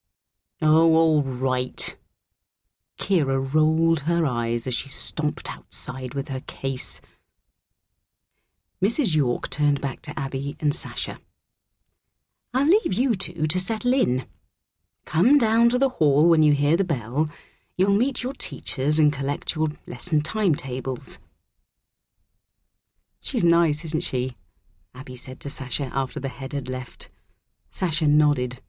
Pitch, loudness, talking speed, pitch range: 140 Hz, -23 LUFS, 130 wpm, 120-165 Hz